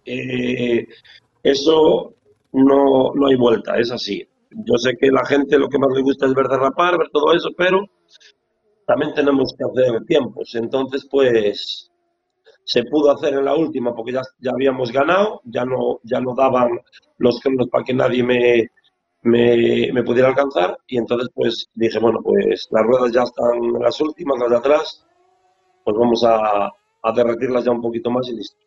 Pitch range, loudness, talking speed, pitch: 120-150 Hz, -18 LUFS, 180 wpm, 130 Hz